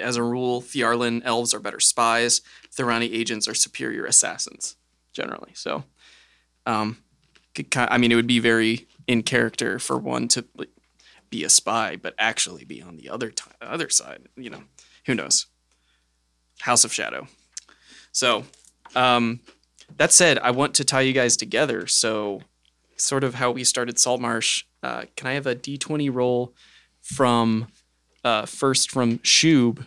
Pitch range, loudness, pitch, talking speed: 110-125 Hz, -21 LUFS, 120 Hz, 155 wpm